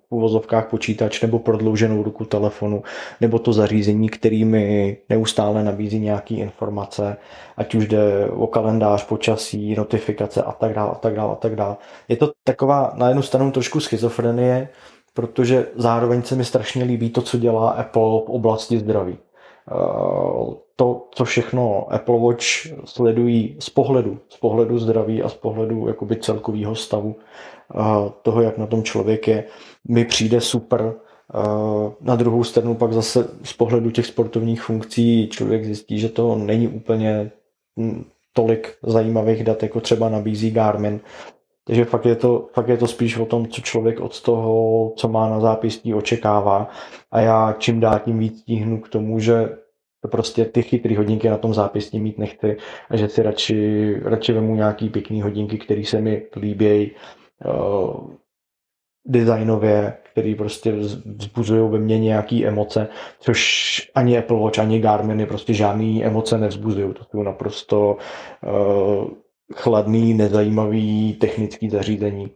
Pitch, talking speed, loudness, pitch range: 110 Hz, 145 wpm, -20 LUFS, 105-115 Hz